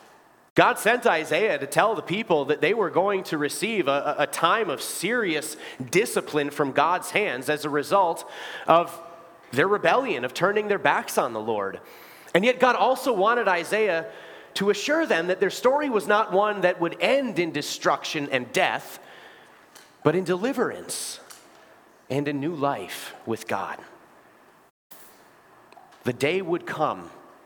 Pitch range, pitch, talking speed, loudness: 150-205 Hz, 175 Hz, 155 wpm, -24 LUFS